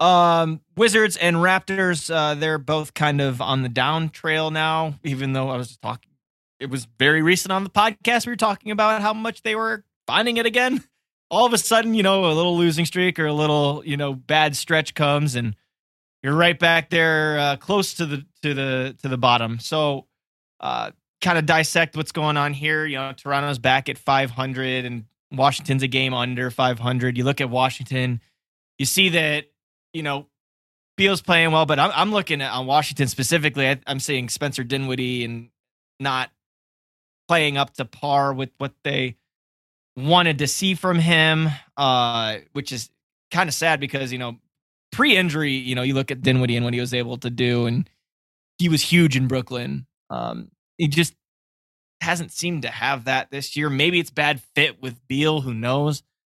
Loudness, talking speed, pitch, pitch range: -21 LUFS, 190 wpm, 145 Hz, 130-165 Hz